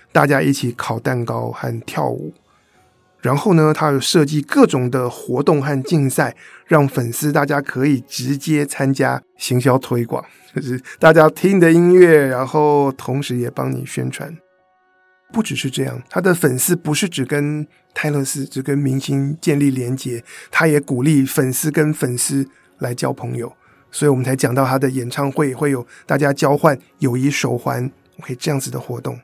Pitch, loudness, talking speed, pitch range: 140 Hz, -17 LUFS, 255 characters per minute, 130-155 Hz